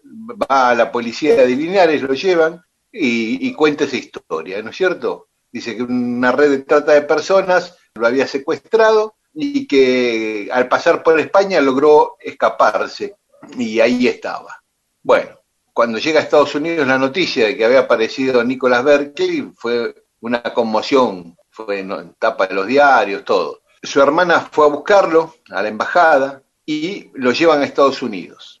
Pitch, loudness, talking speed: 160 Hz, -15 LUFS, 160 wpm